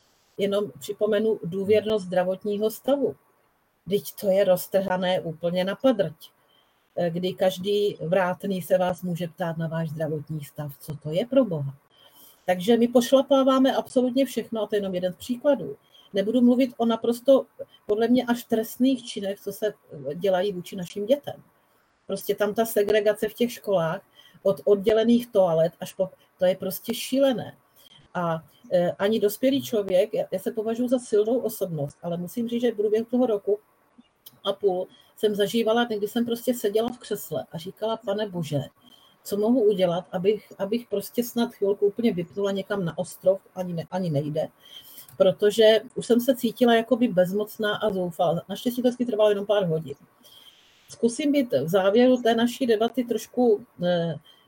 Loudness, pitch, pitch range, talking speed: -25 LUFS, 205 Hz, 185-230 Hz, 160 wpm